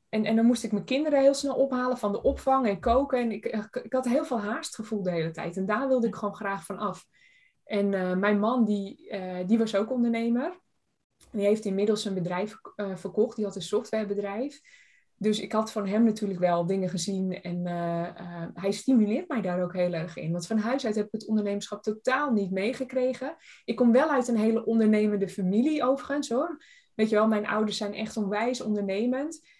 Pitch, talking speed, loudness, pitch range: 215 Hz, 215 wpm, -28 LUFS, 200-250 Hz